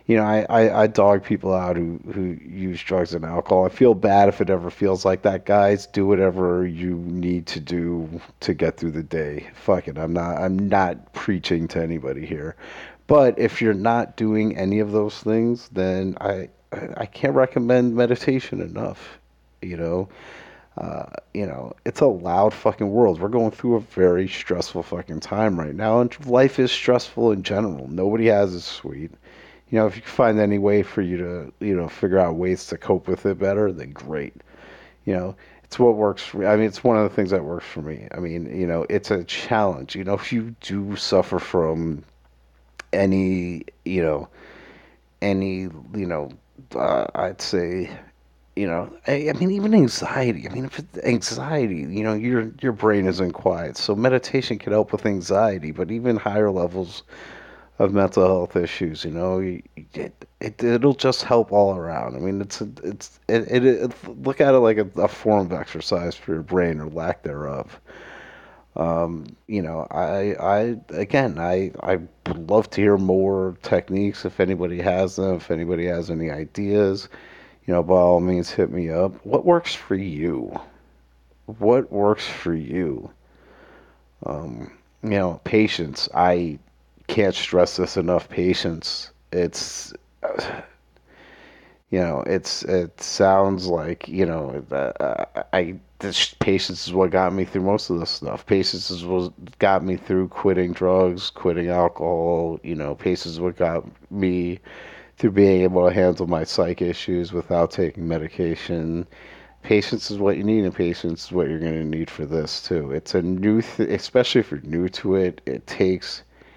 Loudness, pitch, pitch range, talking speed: -22 LUFS, 95 Hz, 85-105 Hz, 180 wpm